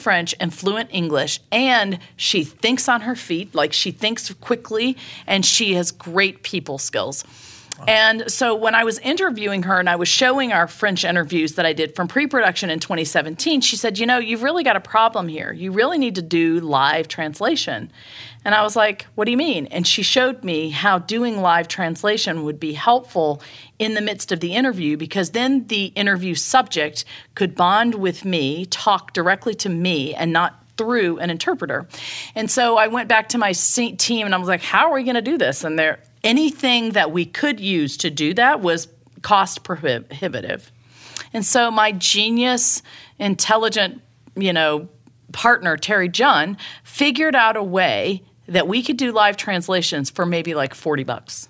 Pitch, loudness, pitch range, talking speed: 190 Hz, -18 LUFS, 165-225 Hz, 185 wpm